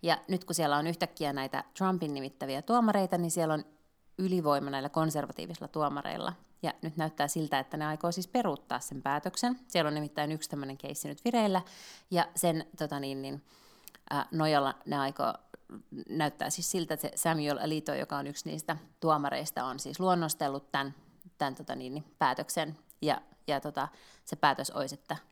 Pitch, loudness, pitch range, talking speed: 155 Hz, -33 LUFS, 145-175 Hz, 170 wpm